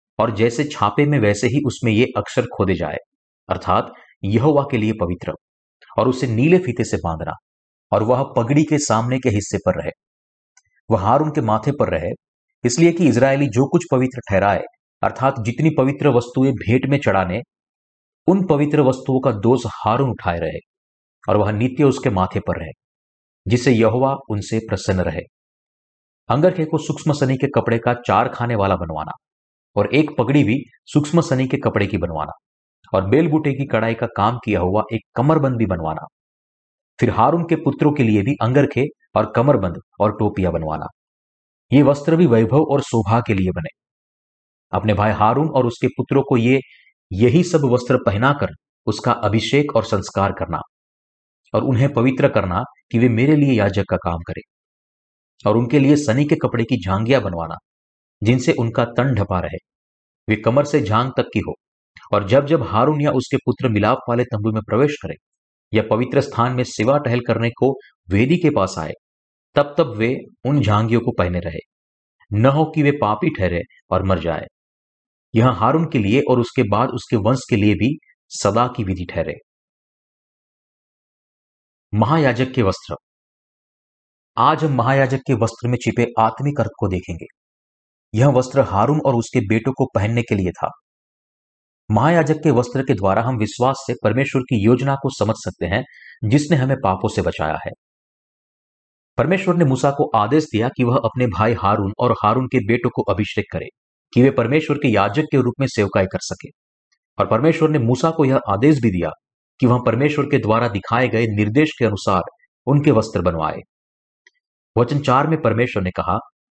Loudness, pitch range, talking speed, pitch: -18 LUFS, 100-135 Hz, 175 wpm, 120 Hz